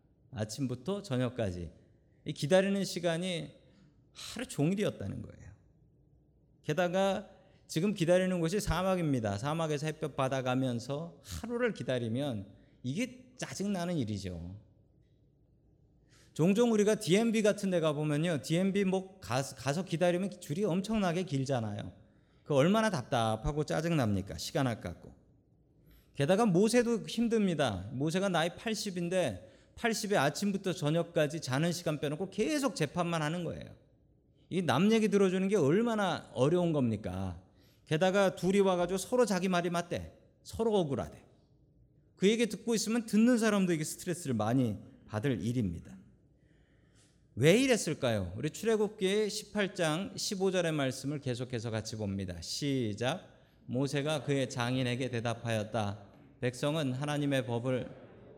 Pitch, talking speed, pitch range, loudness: 150 Hz, 295 characters per minute, 125-190 Hz, -32 LUFS